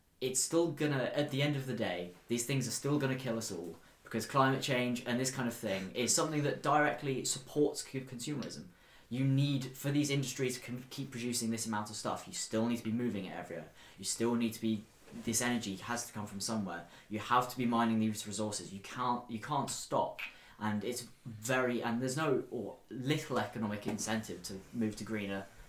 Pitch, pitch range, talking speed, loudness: 120 Hz, 110-130 Hz, 210 wpm, -35 LUFS